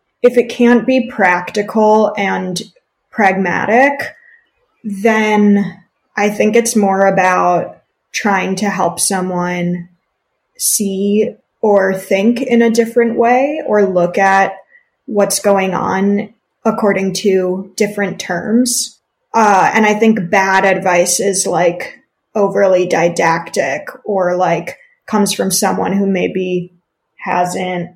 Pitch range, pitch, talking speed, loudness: 185-230 Hz, 200 Hz, 110 wpm, -14 LUFS